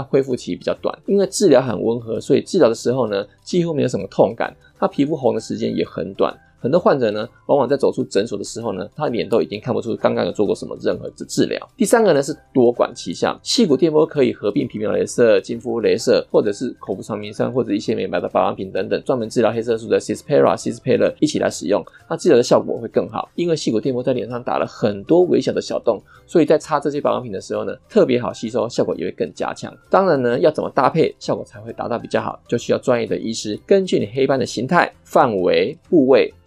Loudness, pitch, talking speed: -19 LUFS, 185 Hz, 390 characters per minute